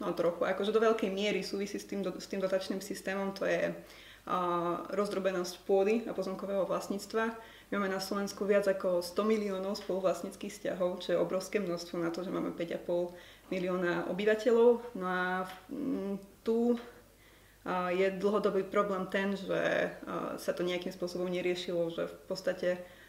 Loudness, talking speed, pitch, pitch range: -33 LUFS, 160 wpm, 190 Hz, 180-205 Hz